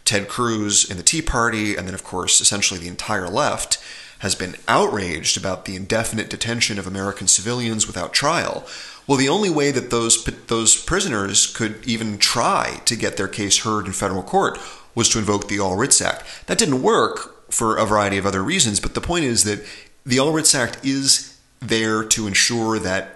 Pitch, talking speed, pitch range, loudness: 110 Hz, 195 wpm, 100-120 Hz, -19 LUFS